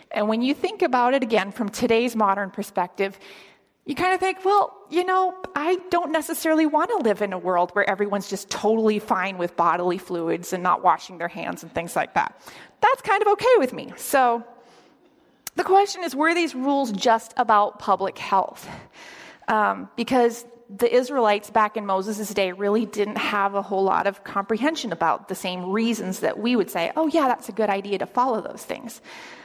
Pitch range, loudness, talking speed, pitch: 200-305 Hz, -23 LUFS, 195 wpm, 230 Hz